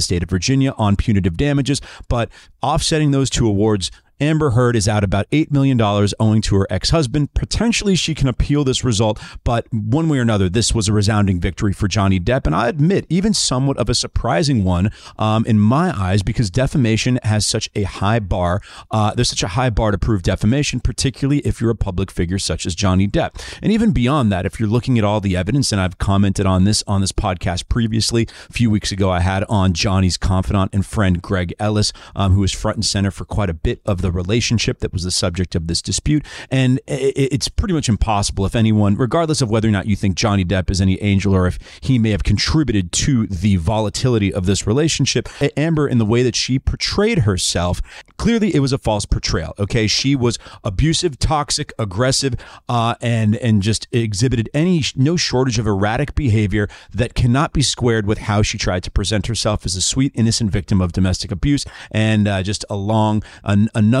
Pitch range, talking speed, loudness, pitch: 100-130 Hz, 205 wpm, -18 LUFS, 110 Hz